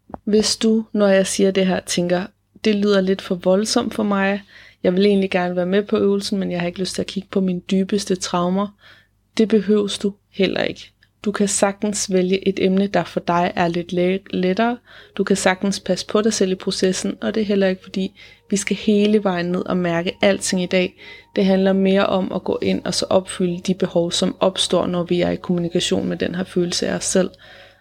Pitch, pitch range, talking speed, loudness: 195 Hz, 185-205 Hz, 220 wpm, -20 LUFS